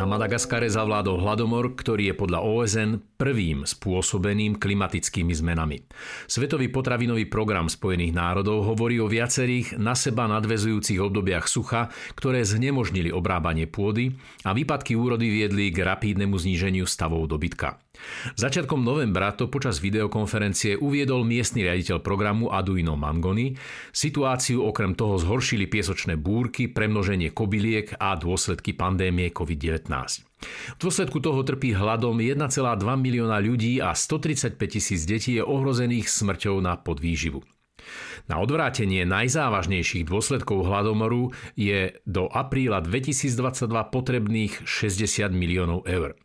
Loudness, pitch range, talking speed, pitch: -25 LUFS, 95-120 Hz, 120 wpm, 105 Hz